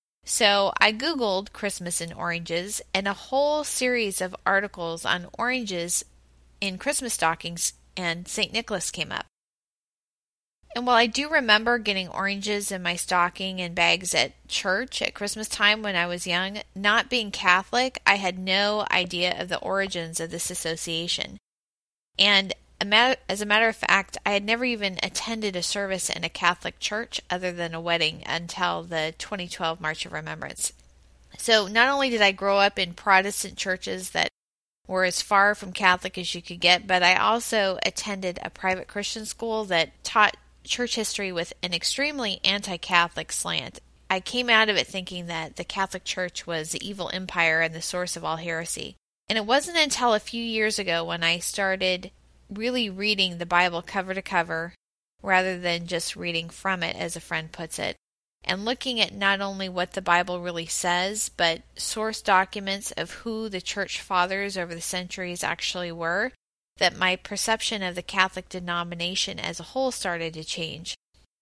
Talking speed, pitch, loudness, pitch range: 175 wpm, 185 Hz, -25 LUFS, 175-210 Hz